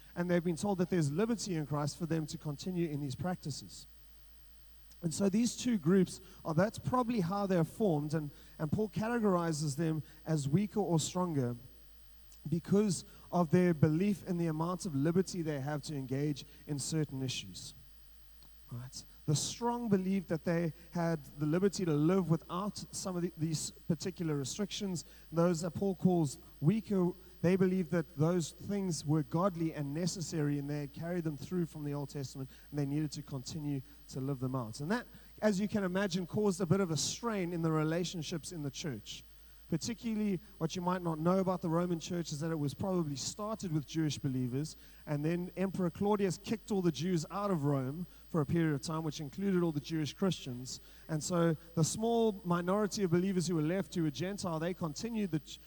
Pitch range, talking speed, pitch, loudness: 150-185 Hz, 190 wpm, 170 Hz, -35 LUFS